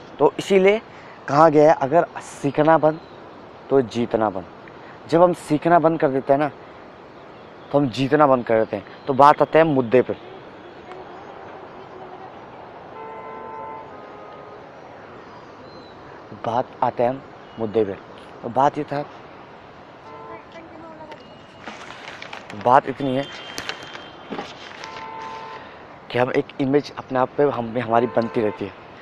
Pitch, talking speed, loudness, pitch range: 135 Hz, 115 wpm, -20 LUFS, 120-150 Hz